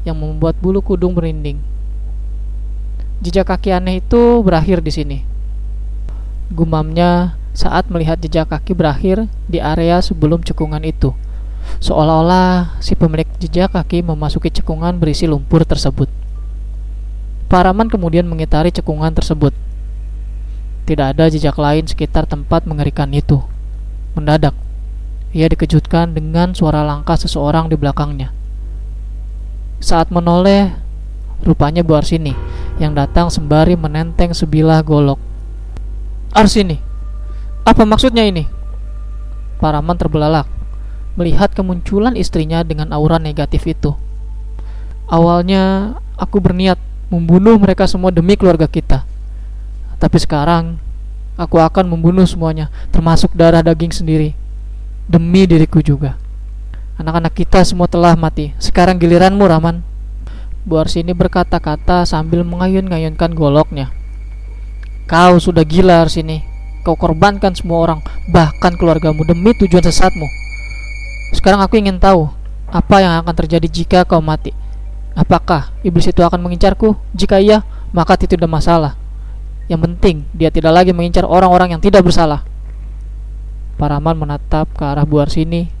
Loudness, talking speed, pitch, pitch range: -13 LUFS, 115 wpm, 165 Hz, 150-180 Hz